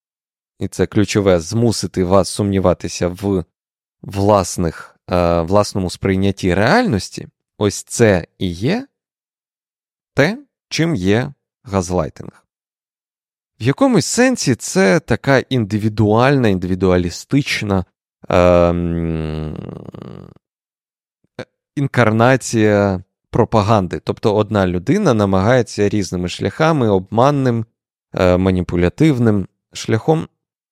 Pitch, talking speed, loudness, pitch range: 105 Hz, 80 wpm, -16 LUFS, 90-120 Hz